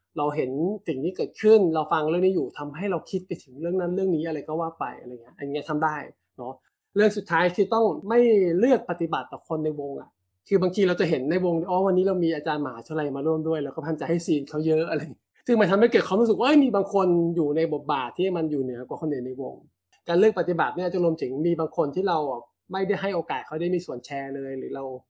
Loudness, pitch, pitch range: -25 LUFS, 165 Hz, 150-185 Hz